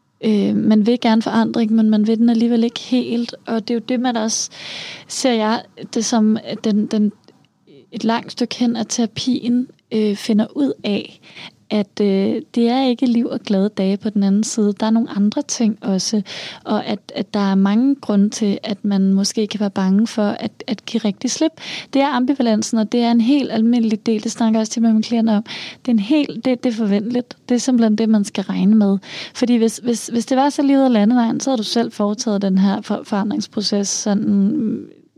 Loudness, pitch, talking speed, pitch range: -18 LUFS, 225 Hz, 215 wpm, 210-240 Hz